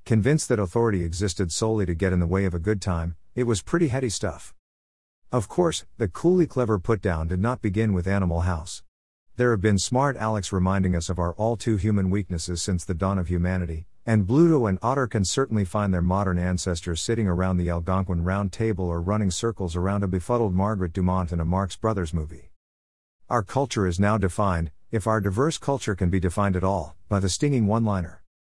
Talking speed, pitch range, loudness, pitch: 205 wpm, 90-110 Hz, -25 LUFS, 95 Hz